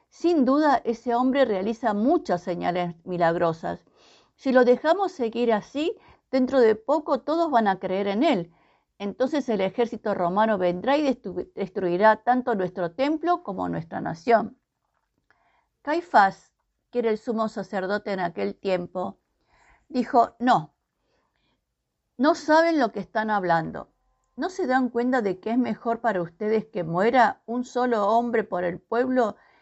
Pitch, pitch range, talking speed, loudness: 230 Hz, 195-260 Hz, 140 wpm, -24 LUFS